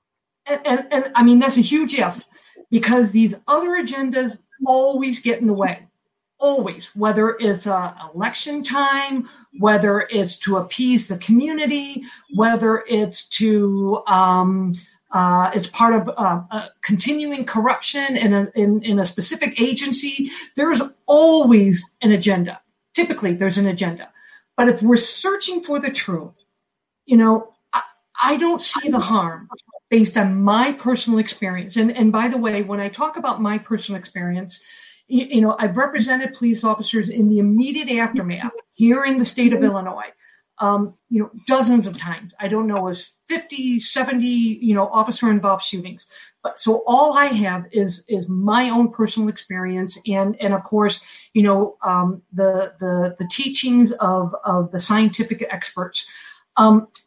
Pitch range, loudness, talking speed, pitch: 200-255 Hz, -19 LUFS, 160 wpm, 225 Hz